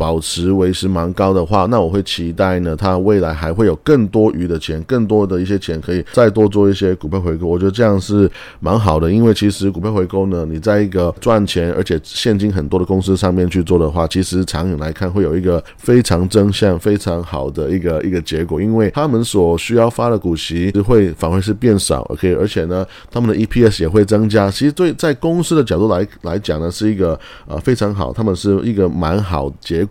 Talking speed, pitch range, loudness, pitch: 335 characters per minute, 85-105 Hz, -15 LUFS, 95 Hz